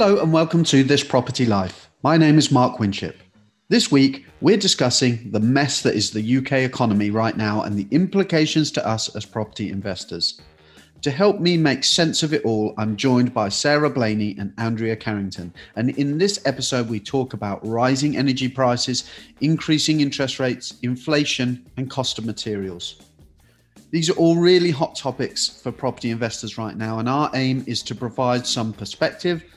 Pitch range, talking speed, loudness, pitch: 105-145 Hz, 175 wpm, -20 LUFS, 125 Hz